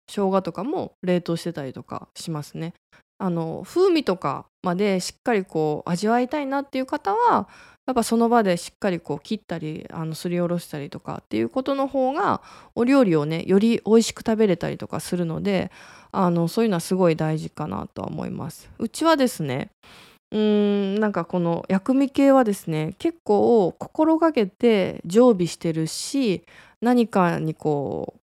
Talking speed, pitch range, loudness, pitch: 340 characters per minute, 170-240 Hz, -23 LUFS, 195 Hz